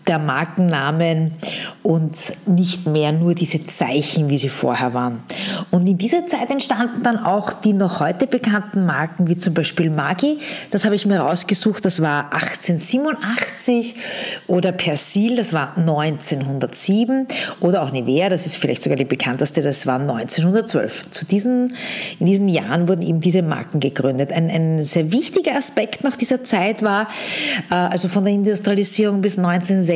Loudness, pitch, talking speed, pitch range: -19 LUFS, 180 Hz, 155 wpm, 160-215 Hz